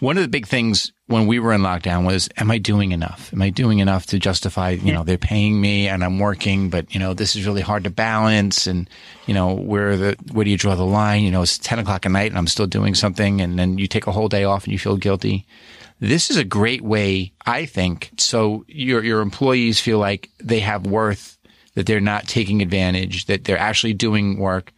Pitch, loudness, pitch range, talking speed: 100 Hz, -19 LUFS, 95-110 Hz, 240 wpm